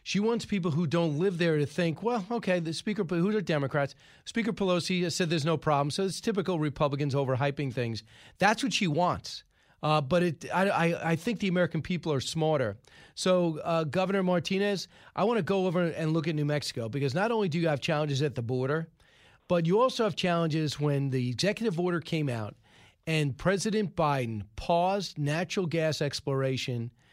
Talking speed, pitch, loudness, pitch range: 190 wpm, 165 Hz, -29 LUFS, 145-185 Hz